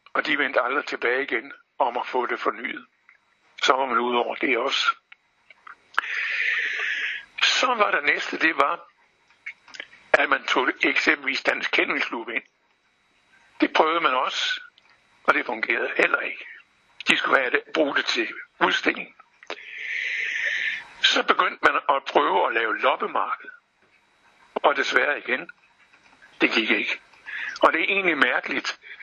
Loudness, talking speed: -23 LUFS, 140 wpm